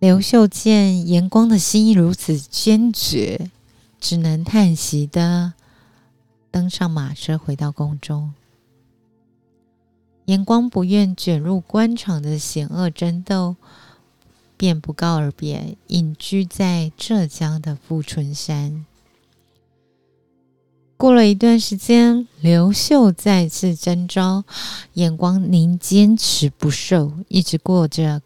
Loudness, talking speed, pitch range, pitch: -17 LUFS, 160 characters per minute, 150-190 Hz, 170 Hz